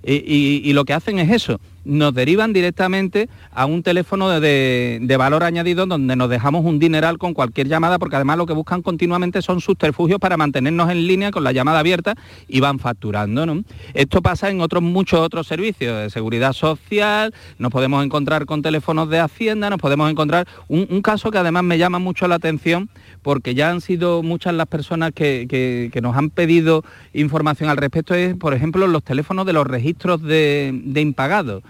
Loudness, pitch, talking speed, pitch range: -18 LUFS, 160 Hz, 195 wpm, 140-180 Hz